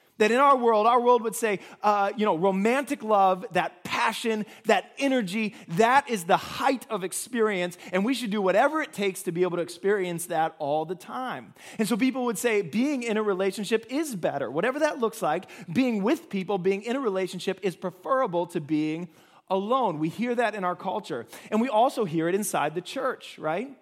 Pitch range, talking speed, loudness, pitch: 185-240 Hz, 205 wpm, -26 LUFS, 210 Hz